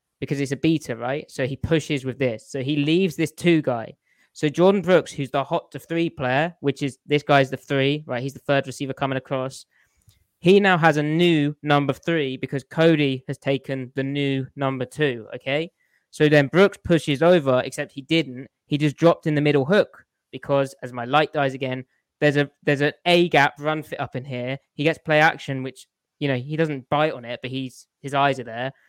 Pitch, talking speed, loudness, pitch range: 140 Hz, 215 wpm, -22 LUFS, 130-155 Hz